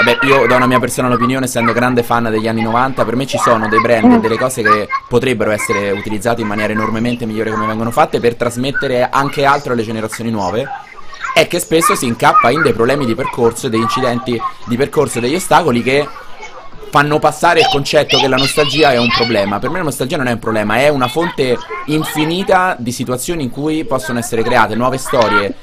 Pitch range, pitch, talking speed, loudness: 115-150 Hz, 125 Hz, 205 wpm, -13 LUFS